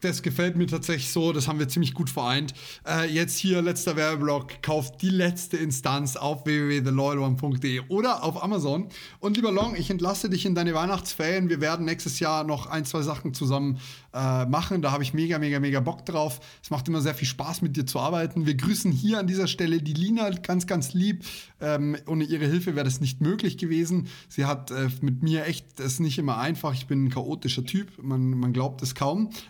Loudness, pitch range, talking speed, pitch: -26 LUFS, 140-175 Hz, 210 wpm, 155 Hz